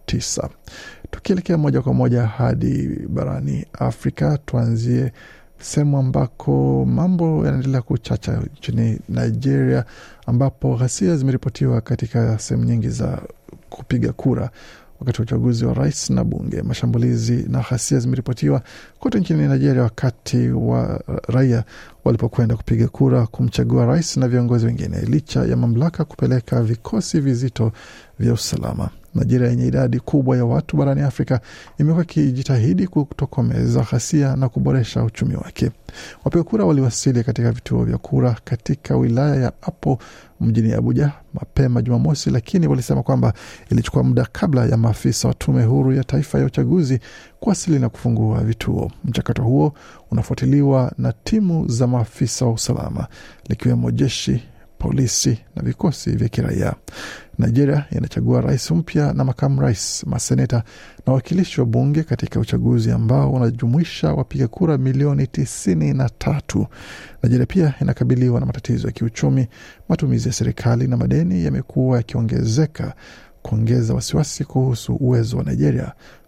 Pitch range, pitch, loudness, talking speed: 115-140 Hz, 125 Hz, -19 LUFS, 130 wpm